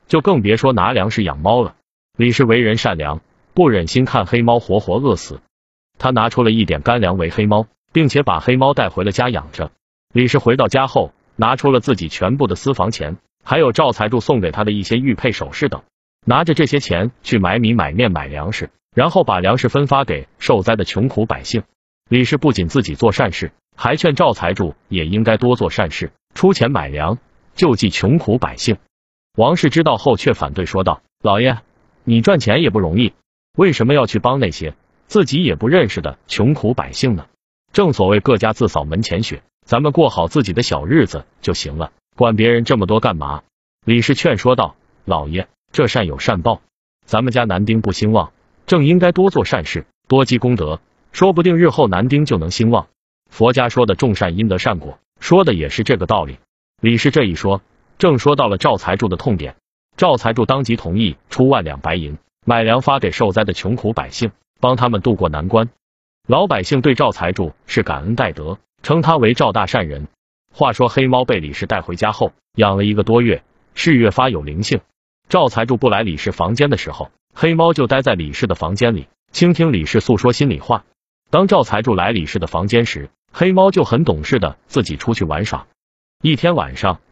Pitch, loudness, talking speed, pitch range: 115 Hz, -16 LUFS, 285 characters per minute, 95-130 Hz